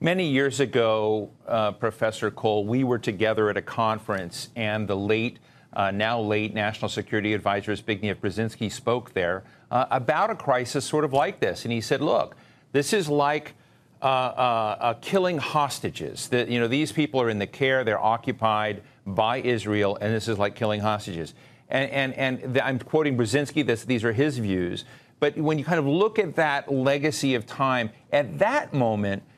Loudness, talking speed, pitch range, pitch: -25 LUFS, 185 wpm, 110-140 Hz, 120 Hz